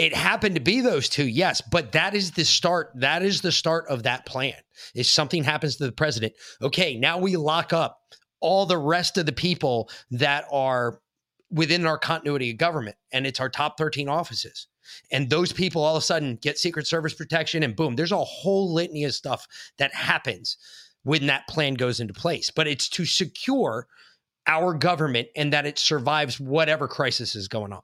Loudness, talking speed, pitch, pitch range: -24 LUFS, 195 wpm, 155 Hz, 135-170 Hz